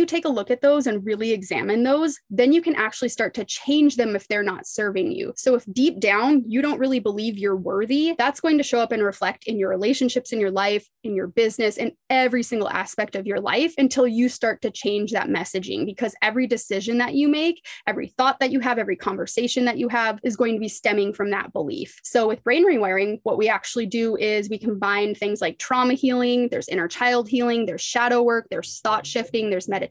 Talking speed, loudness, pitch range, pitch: 230 wpm, -22 LUFS, 205-255 Hz, 230 Hz